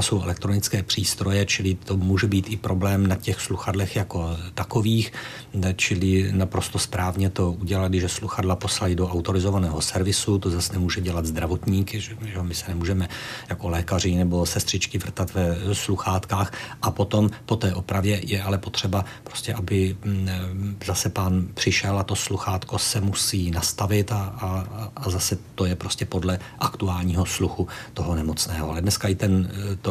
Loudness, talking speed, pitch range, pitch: -24 LUFS, 160 wpm, 90-105 Hz, 95 Hz